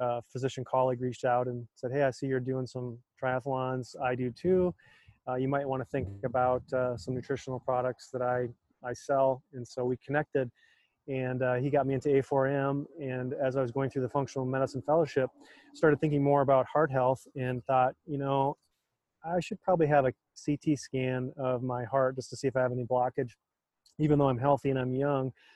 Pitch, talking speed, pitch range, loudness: 130 Hz, 205 wpm, 125-140 Hz, -31 LUFS